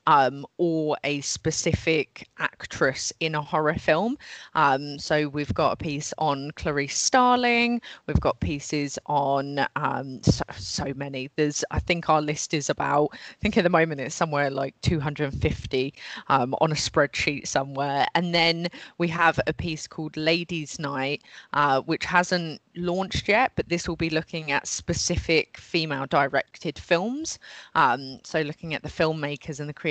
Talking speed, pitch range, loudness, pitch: 160 wpm, 140-165 Hz, -25 LUFS, 150 Hz